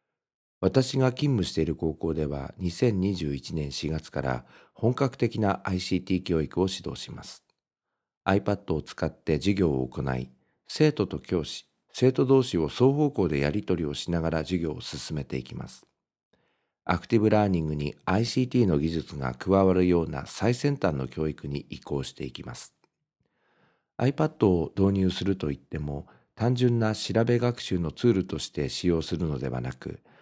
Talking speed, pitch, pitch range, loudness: 305 characters per minute, 90 Hz, 75-105 Hz, -27 LUFS